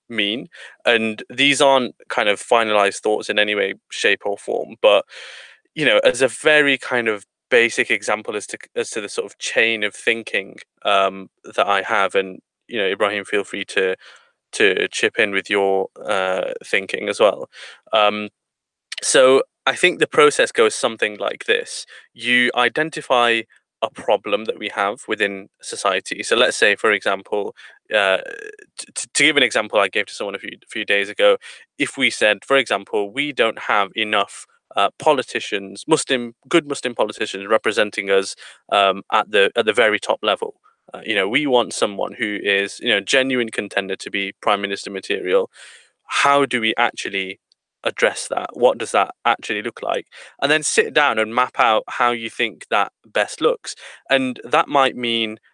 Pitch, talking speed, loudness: 135 Hz, 180 wpm, -19 LUFS